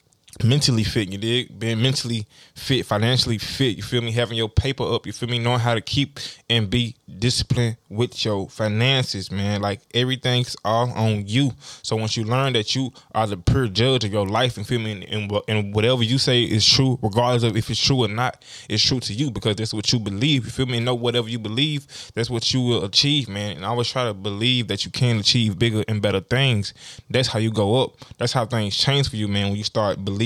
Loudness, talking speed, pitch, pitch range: -21 LUFS, 240 wpm, 115 Hz, 105-125 Hz